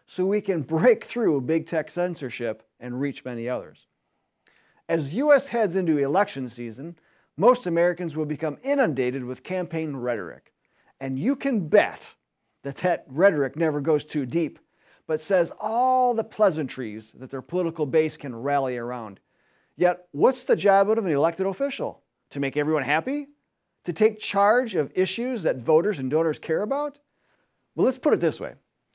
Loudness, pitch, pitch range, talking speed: -24 LUFS, 160 Hz, 140-200 Hz, 160 wpm